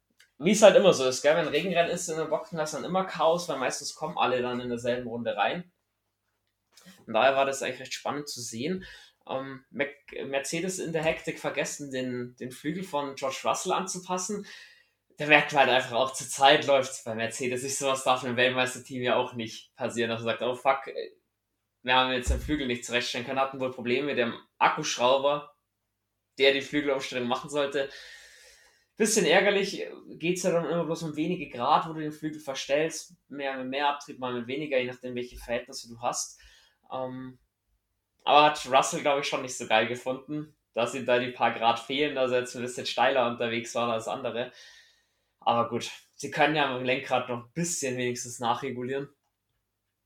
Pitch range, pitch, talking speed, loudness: 120-150 Hz, 135 Hz, 195 wpm, -27 LUFS